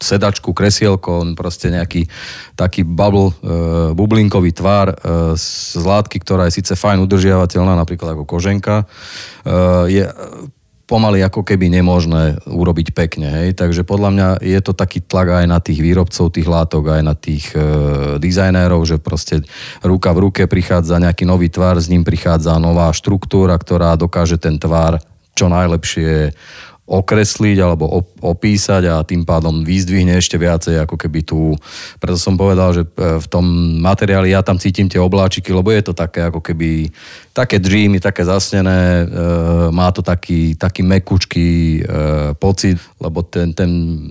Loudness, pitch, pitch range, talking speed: -14 LUFS, 90 Hz, 85-95 Hz, 150 wpm